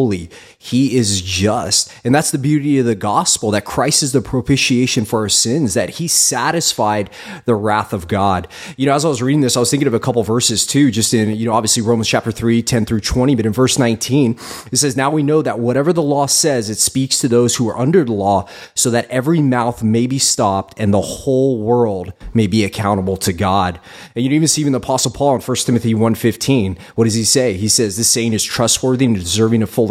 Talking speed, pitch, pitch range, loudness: 240 wpm, 120 Hz, 110-135 Hz, -15 LUFS